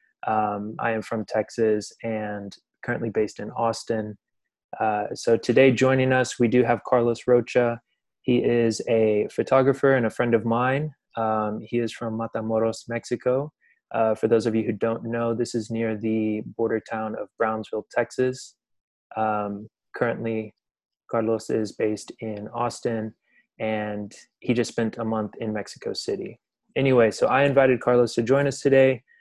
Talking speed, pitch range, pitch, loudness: 160 wpm, 110-120 Hz, 115 Hz, -24 LUFS